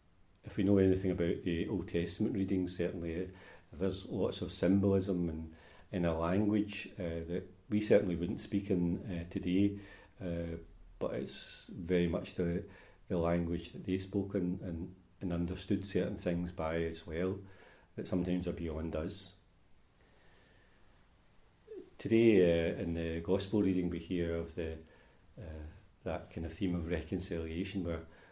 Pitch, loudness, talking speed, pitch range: 90 Hz, -35 LUFS, 150 wpm, 85-95 Hz